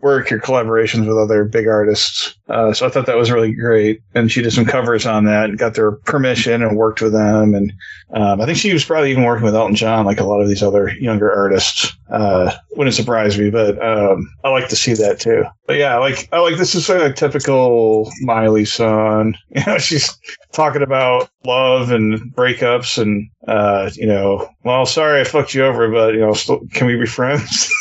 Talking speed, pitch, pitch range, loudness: 220 wpm, 115 Hz, 110-130 Hz, -15 LUFS